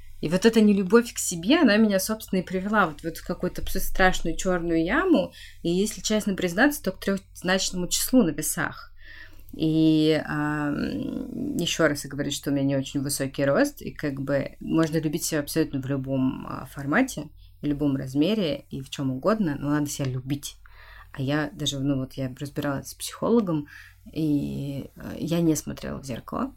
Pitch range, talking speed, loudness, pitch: 140-190 Hz, 175 wpm, -25 LUFS, 155 Hz